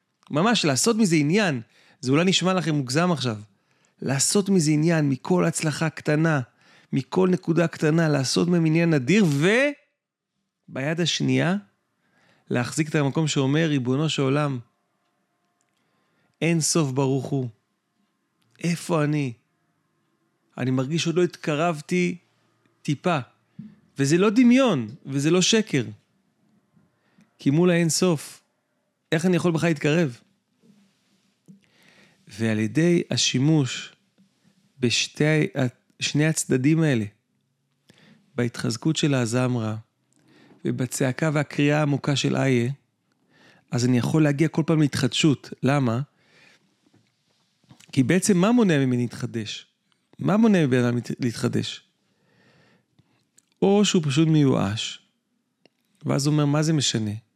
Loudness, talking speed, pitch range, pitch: -22 LUFS, 110 wpm, 130-180 Hz, 155 Hz